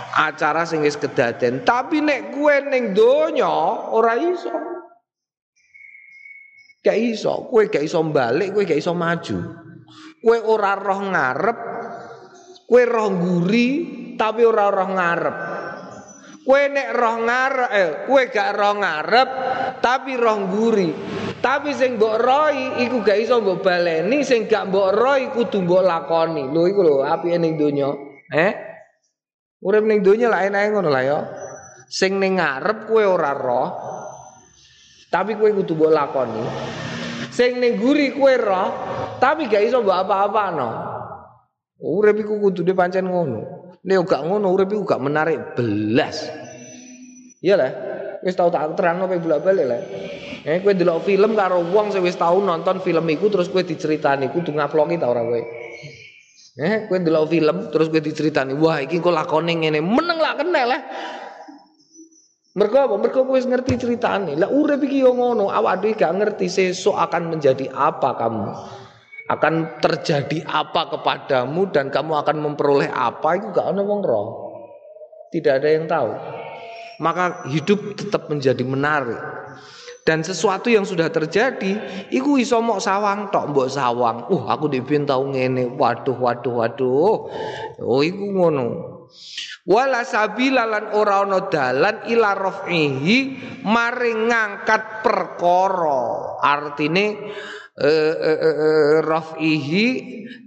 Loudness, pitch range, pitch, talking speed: -19 LUFS, 160-240 Hz, 195 Hz, 135 wpm